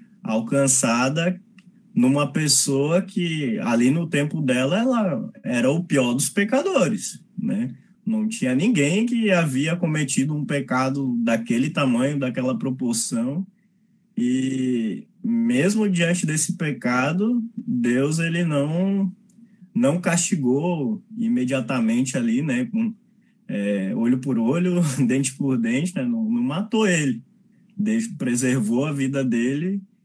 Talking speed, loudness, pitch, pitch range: 115 wpm, -22 LUFS, 180 Hz, 135-220 Hz